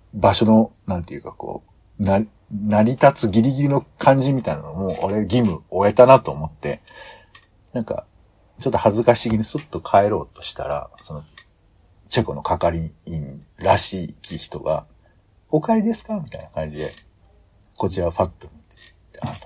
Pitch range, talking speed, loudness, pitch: 95-125 Hz, 300 characters per minute, -20 LUFS, 105 Hz